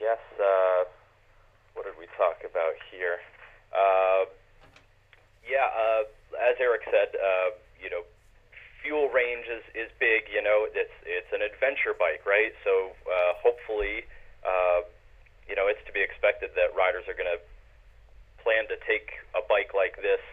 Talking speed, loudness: 155 wpm, -27 LUFS